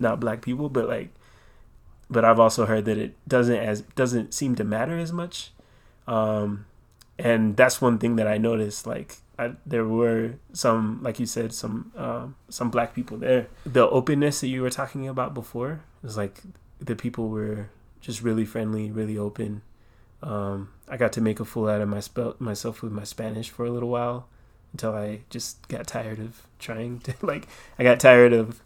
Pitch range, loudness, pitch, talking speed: 110-120 Hz, -25 LUFS, 115 Hz, 195 wpm